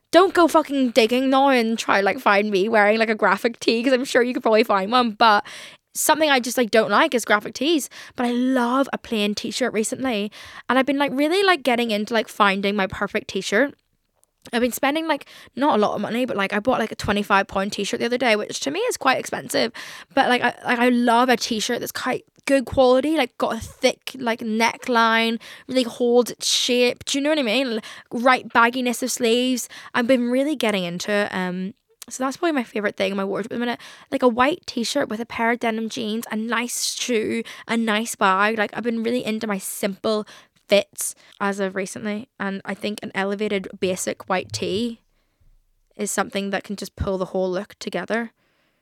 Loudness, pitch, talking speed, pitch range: -21 LUFS, 230 Hz, 225 wpm, 205-255 Hz